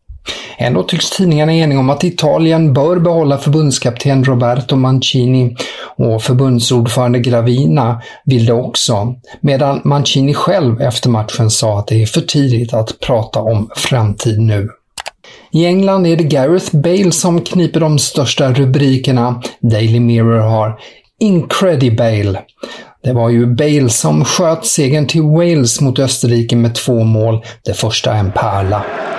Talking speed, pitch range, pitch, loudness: 140 wpm, 115-150 Hz, 130 Hz, -12 LUFS